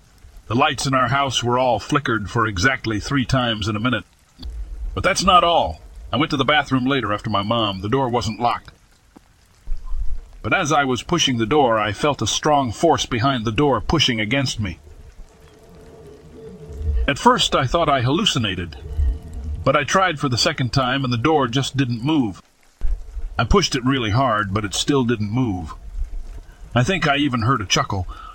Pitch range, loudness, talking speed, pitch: 90-135 Hz, -19 LUFS, 180 wpm, 120 Hz